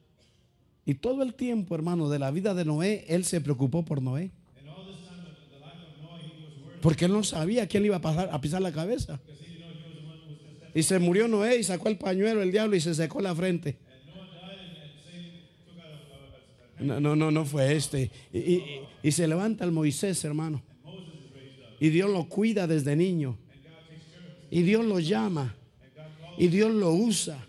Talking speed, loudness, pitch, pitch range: 155 wpm, -27 LUFS, 165 Hz, 150-185 Hz